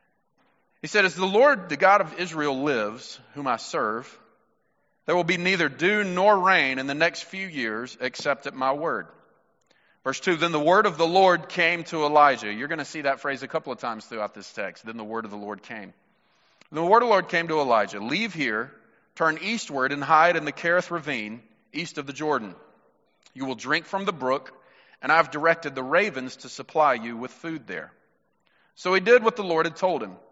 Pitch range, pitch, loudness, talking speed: 135-180 Hz, 155 Hz, -24 LUFS, 215 wpm